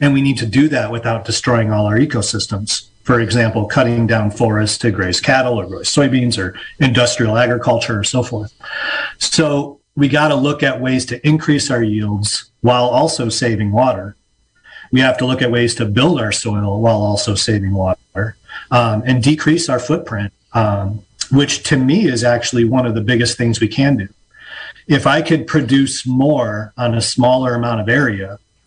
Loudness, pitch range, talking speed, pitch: -15 LUFS, 105-135 Hz, 180 wpm, 120 Hz